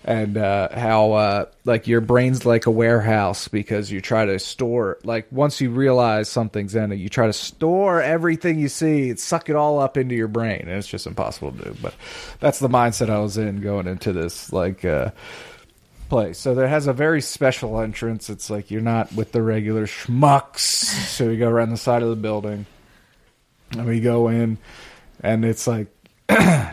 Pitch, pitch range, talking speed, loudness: 115 Hz, 110-130 Hz, 195 wpm, -20 LUFS